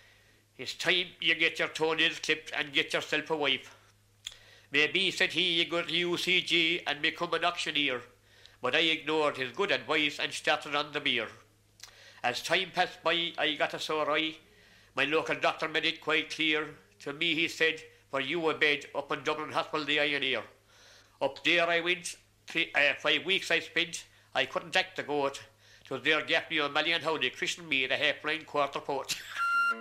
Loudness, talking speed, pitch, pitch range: -29 LUFS, 185 wpm, 155 Hz, 135-165 Hz